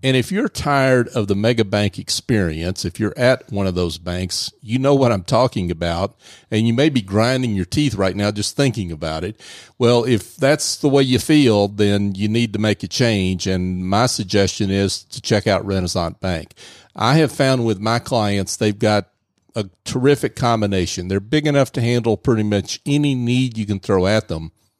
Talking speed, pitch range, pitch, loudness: 200 wpm, 100-125 Hz, 110 Hz, -18 LUFS